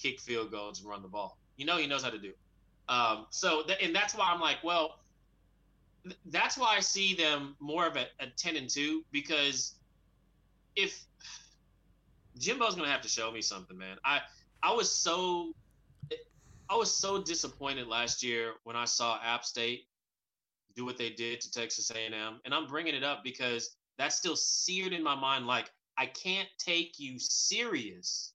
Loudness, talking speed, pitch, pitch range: -32 LUFS, 185 wpm, 130 Hz, 115-165 Hz